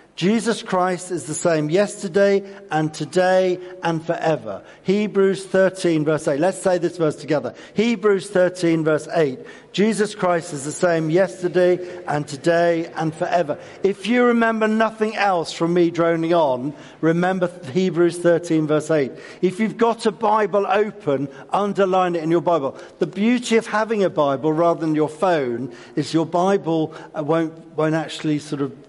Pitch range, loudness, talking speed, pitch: 160-195 Hz, -20 LUFS, 160 wpm, 175 Hz